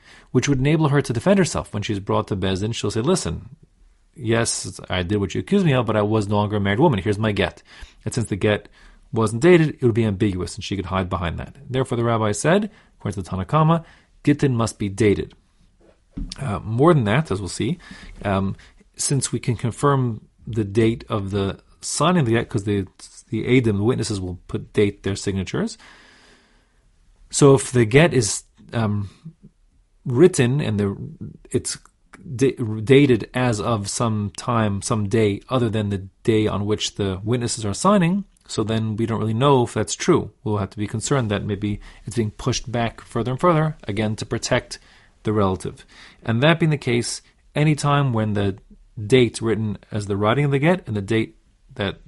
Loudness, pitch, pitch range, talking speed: -21 LUFS, 110 Hz, 105-130 Hz, 195 wpm